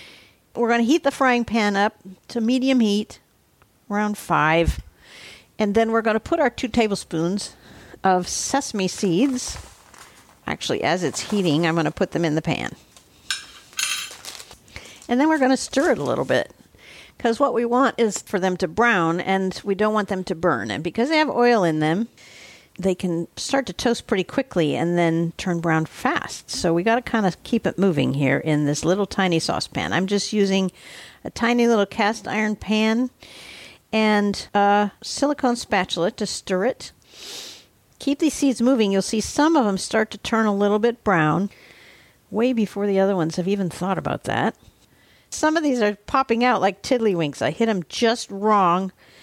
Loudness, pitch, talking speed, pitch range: -21 LUFS, 205 Hz, 185 wpm, 185-235 Hz